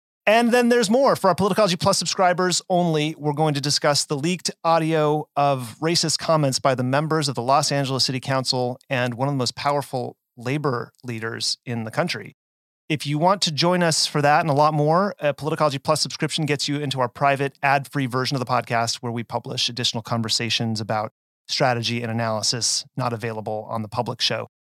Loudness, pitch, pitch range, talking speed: -21 LUFS, 140 Hz, 120-155 Hz, 195 wpm